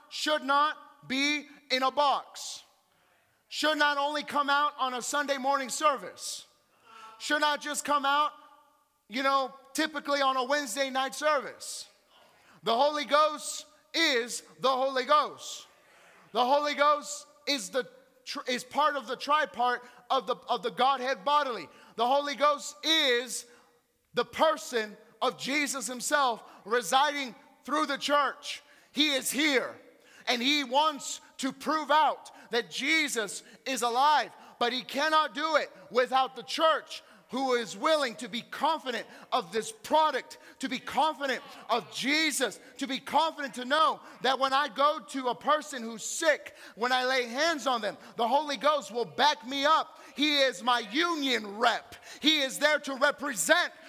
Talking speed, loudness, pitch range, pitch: 155 wpm, -28 LUFS, 255-295 Hz, 280 Hz